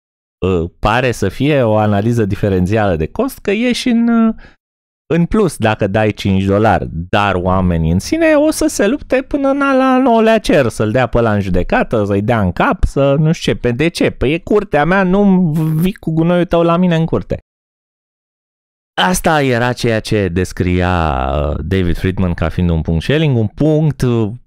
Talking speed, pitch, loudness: 180 wpm, 115 Hz, -14 LUFS